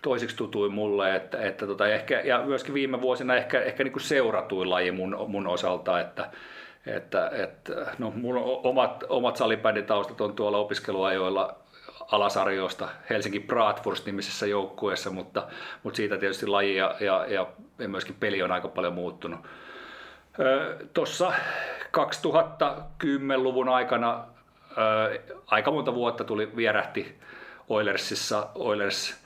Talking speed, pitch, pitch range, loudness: 125 wpm, 110 Hz, 100-125 Hz, -27 LUFS